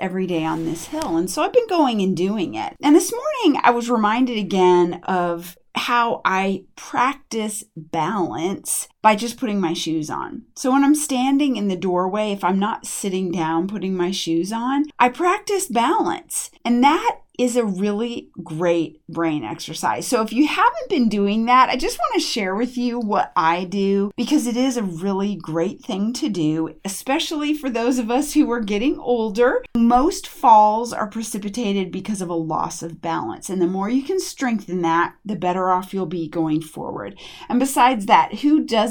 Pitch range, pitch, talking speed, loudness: 180-260 Hz, 215 Hz, 190 wpm, -20 LUFS